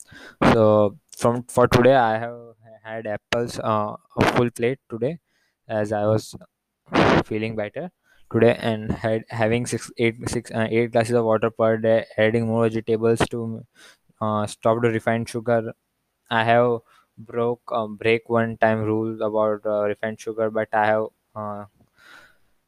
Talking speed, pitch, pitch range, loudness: 155 wpm, 115 Hz, 110-115 Hz, -22 LUFS